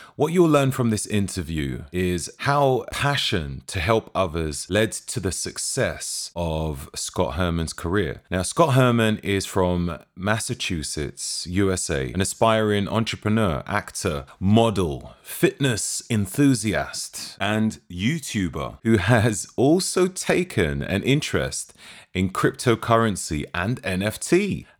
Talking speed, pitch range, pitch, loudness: 110 wpm, 90-120 Hz, 105 Hz, -23 LUFS